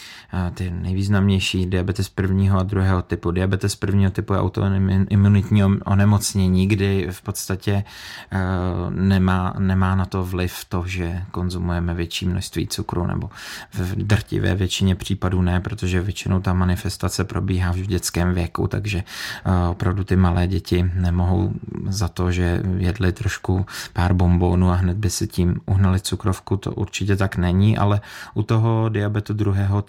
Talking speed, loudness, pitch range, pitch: 140 wpm, -21 LUFS, 90-100 Hz, 95 Hz